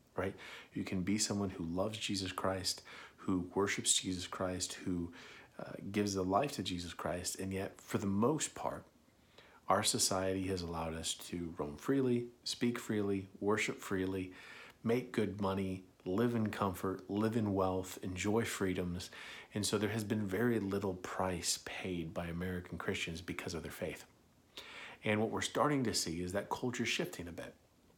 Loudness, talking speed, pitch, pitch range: -37 LUFS, 165 wpm, 95 Hz, 90-105 Hz